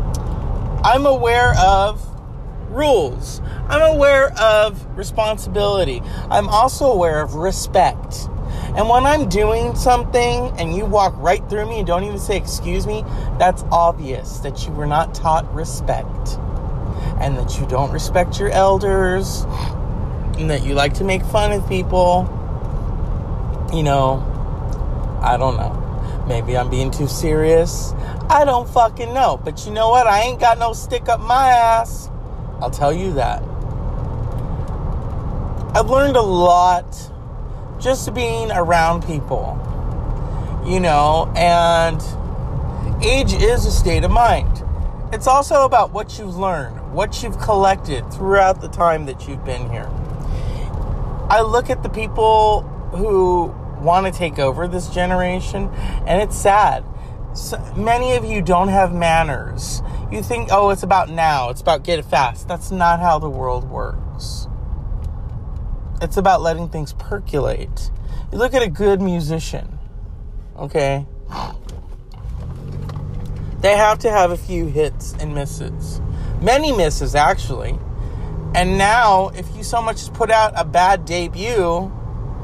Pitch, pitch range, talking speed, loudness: 175 Hz, 135-205 Hz, 140 wpm, -18 LUFS